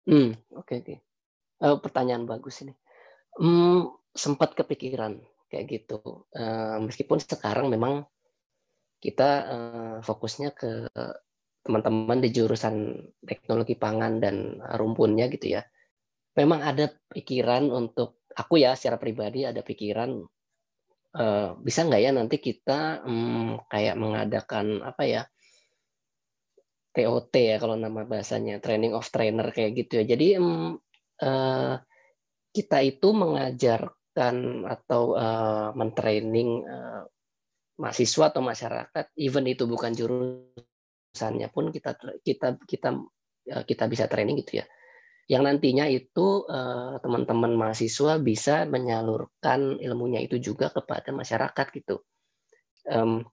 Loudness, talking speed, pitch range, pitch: -27 LUFS, 110 wpm, 110-140 Hz, 120 Hz